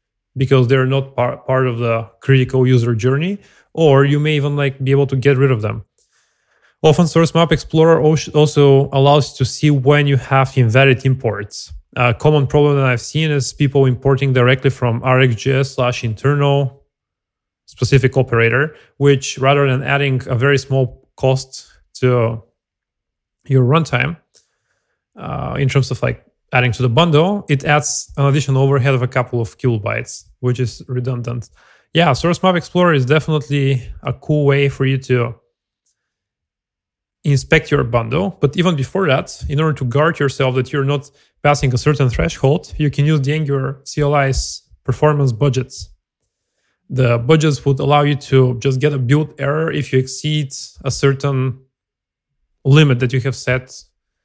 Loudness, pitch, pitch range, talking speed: -15 LUFS, 135 Hz, 125-145 Hz, 160 wpm